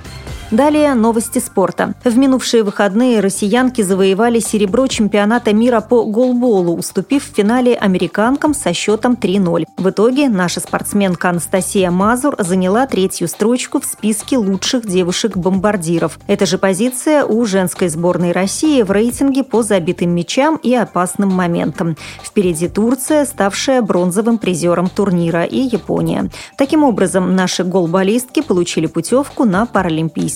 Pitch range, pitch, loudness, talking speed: 185-245 Hz, 205 Hz, -14 LUFS, 125 wpm